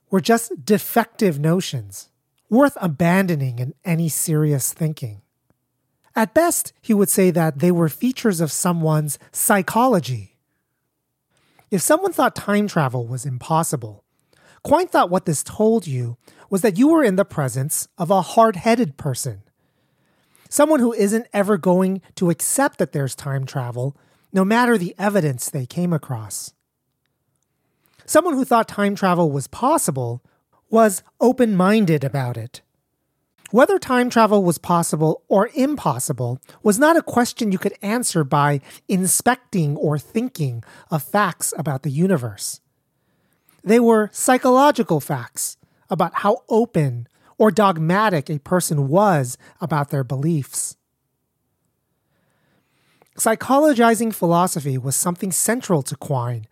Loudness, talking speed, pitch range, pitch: -19 LUFS, 130 wpm, 145-220 Hz, 175 Hz